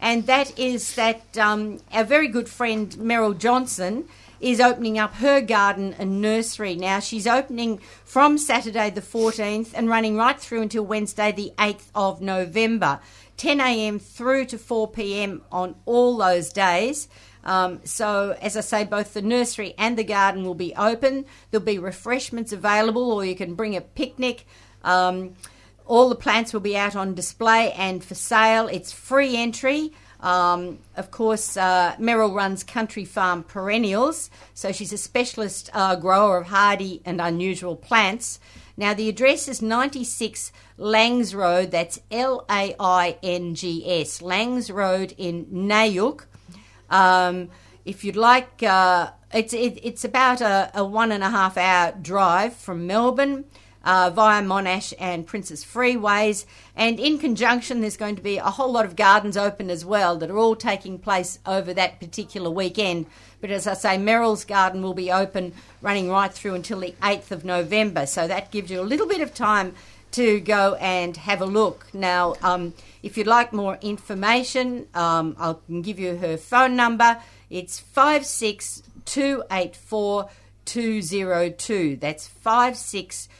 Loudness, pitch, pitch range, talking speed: -22 LUFS, 205 Hz, 185-230 Hz, 160 wpm